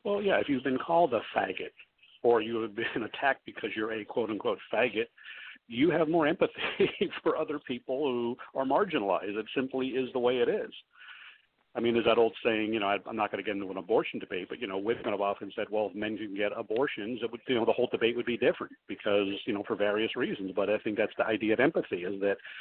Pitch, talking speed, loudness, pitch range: 120 Hz, 240 wpm, -30 LUFS, 105-145 Hz